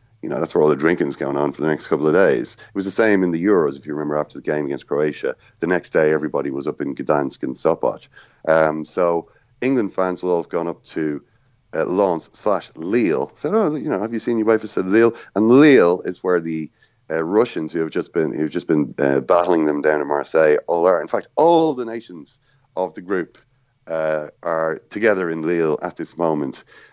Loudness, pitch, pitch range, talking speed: -20 LUFS, 80 Hz, 75-105 Hz, 230 wpm